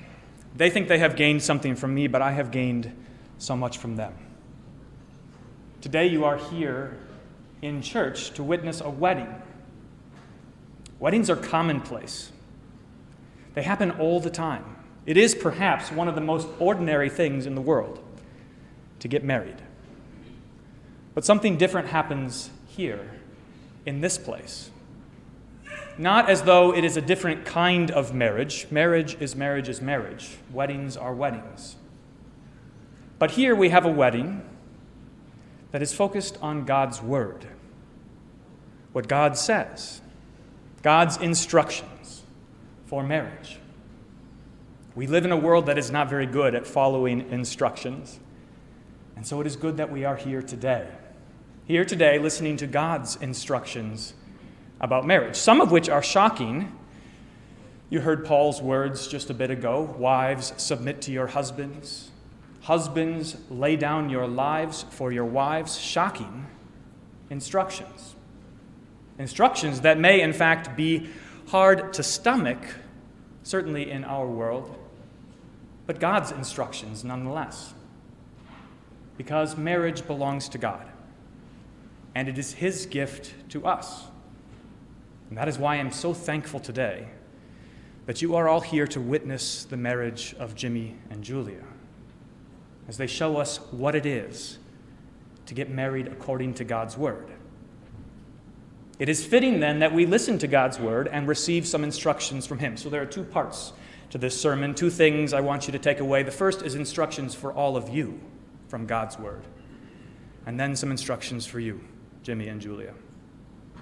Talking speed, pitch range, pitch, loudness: 140 wpm, 130-160 Hz, 145 Hz, -25 LUFS